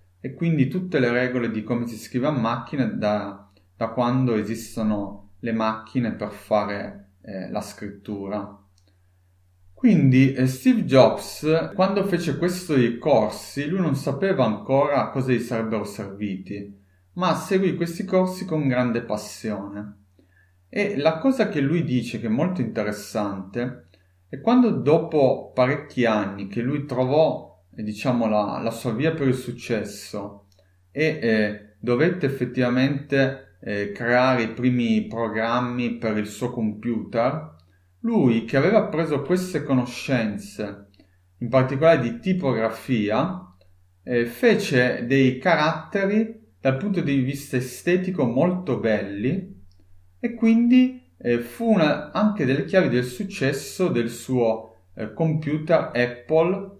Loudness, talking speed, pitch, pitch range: -23 LUFS, 130 wpm, 125 Hz, 105-155 Hz